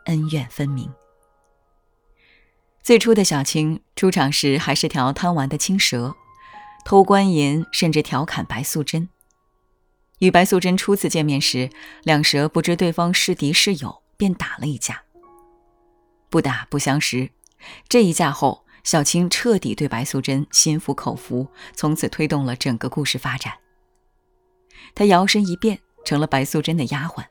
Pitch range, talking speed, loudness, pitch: 130-185 Hz, 220 characters per minute, -19 LUFS, 155 Hz